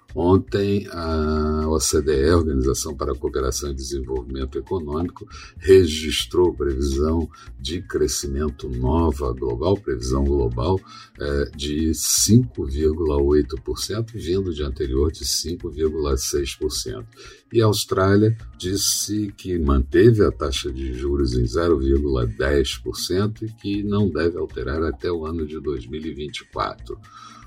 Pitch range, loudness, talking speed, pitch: 70-95 Hz, -22 LUFS, 105 wpm, 80 Hz